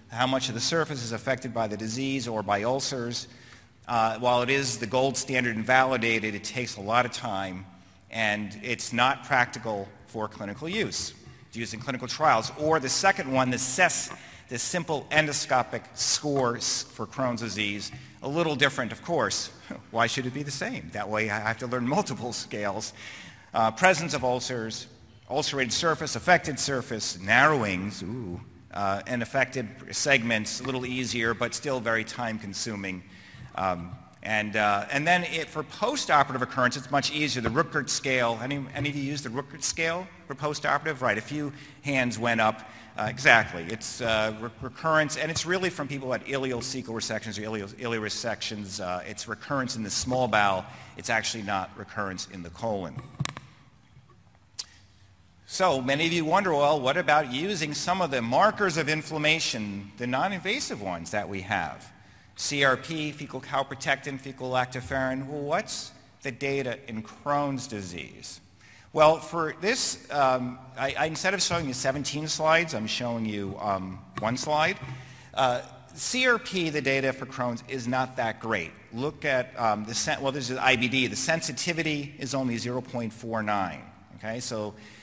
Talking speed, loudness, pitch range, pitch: 165 wpm, -27 LUFS, 110-140 Hz, 125 Hz